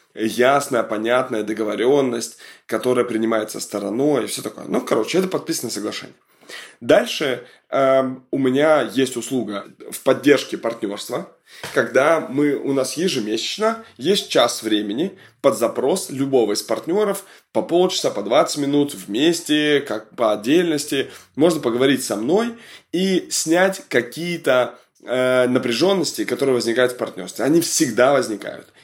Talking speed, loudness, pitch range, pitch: 125 wpm, -20 LUFS, 120-170 Hz, 135 Hz